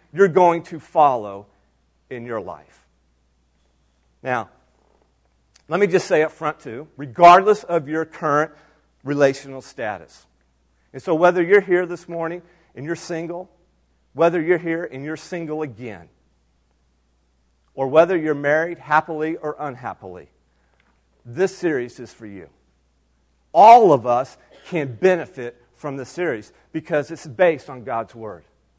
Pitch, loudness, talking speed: 140 Hz, -19 LUFS, 135 wpm